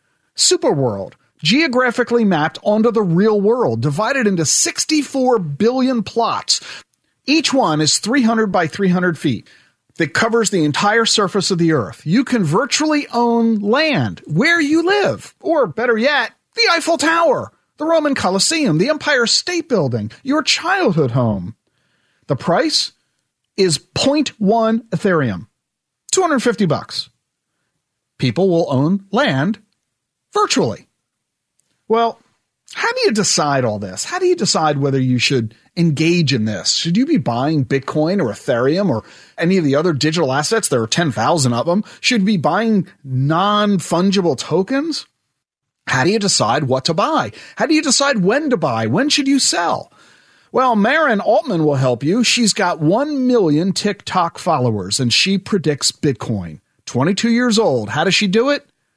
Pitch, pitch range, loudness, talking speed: 195 Hz, 150-245 Hz, -16 LUFS, 150 wpm